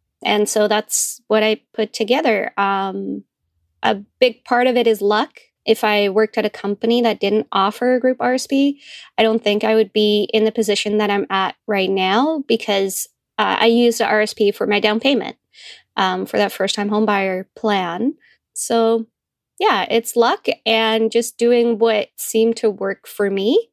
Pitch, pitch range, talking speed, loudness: 220 Hz, 205-235 Hz, 180 wpm, -18 LUFS